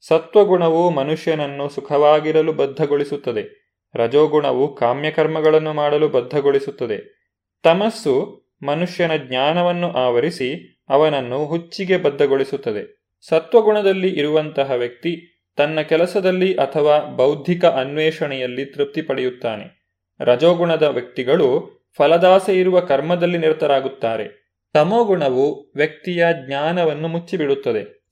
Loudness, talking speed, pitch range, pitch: -18 LUFS, 75 wpm, 145-185 Hz, 160 Hz